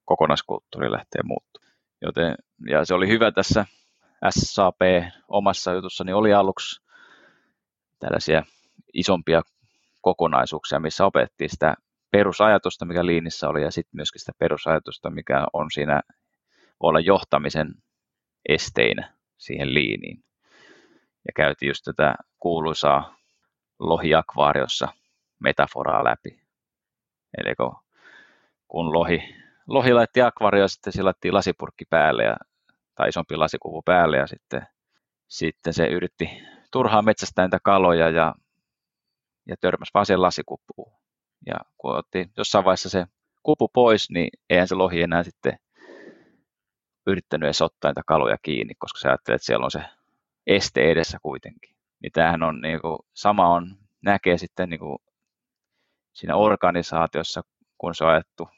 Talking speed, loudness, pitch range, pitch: 125 wpm, -22 LUFS, 80-100 Hz, 90 Hz